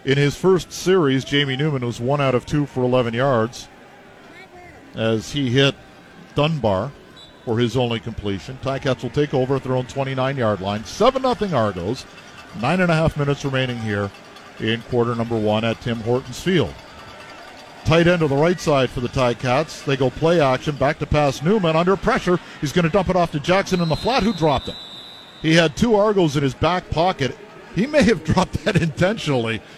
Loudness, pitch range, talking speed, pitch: -20 LUFS, 120-170 Hz, 195 wpm, 140 Hz